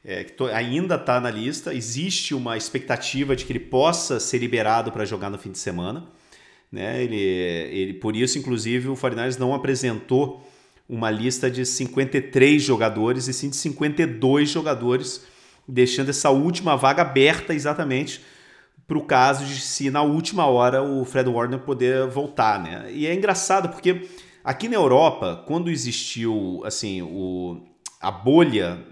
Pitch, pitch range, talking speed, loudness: 130 Hz, 120-145 Hz, 150 wpm, -22 LUFS